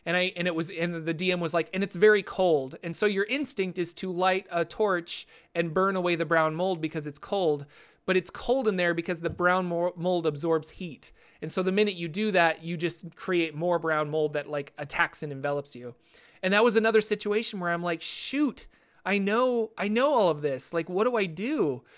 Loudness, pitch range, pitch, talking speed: -27 LUFS, 165-200 Hz, 175 Hz, 225 wpm